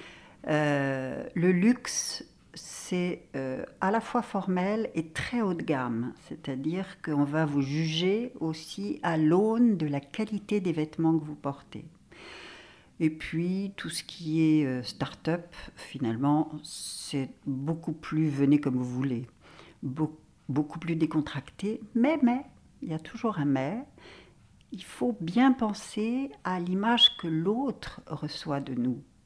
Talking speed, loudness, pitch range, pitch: 140 wpm, -29 LUFS, 145-200 Hz, 160 Hz